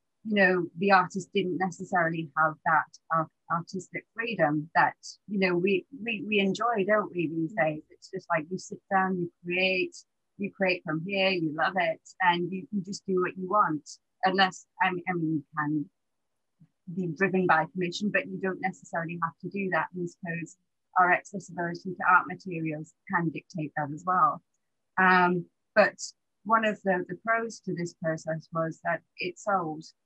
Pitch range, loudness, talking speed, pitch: 165-190 Hz, -28 LUFS, 175 wpm, 180 Hz